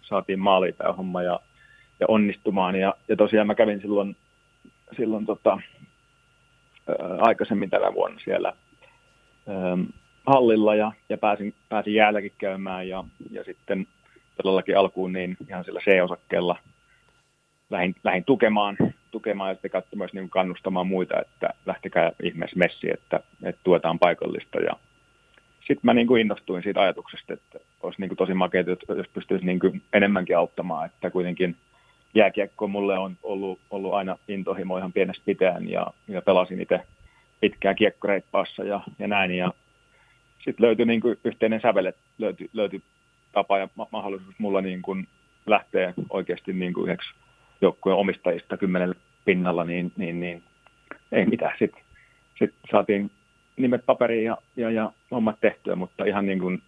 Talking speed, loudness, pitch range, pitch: 145 wpm, -25 LUFS, 95-105 Hz, 95 Hz